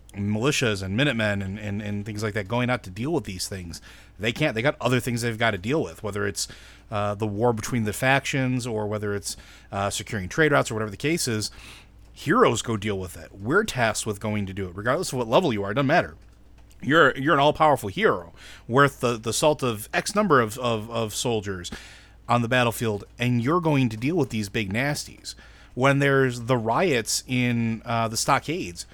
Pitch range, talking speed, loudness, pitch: 105-130 Hz, 220 wpm, -24 LUFS, 115 Hz